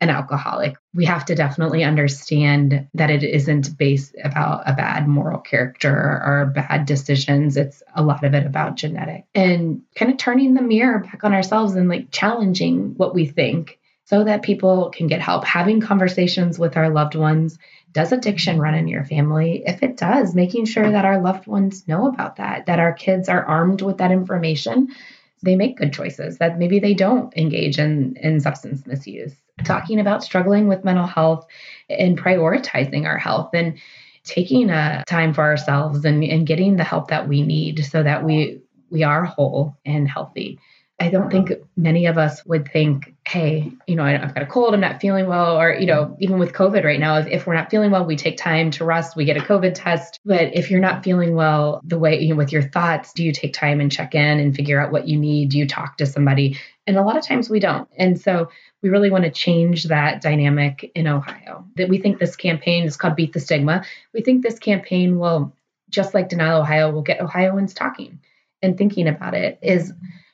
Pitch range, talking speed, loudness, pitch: 150-190 Hz, 210 wpm, -19 LUFS, 165 Hz